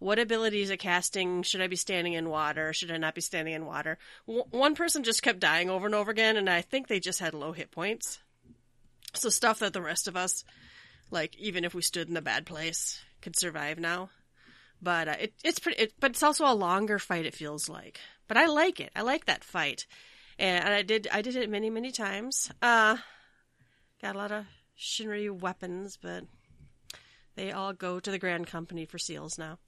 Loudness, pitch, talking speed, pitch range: -30 LUFS, 185 Hz, 215 wpm, 165-220 Hz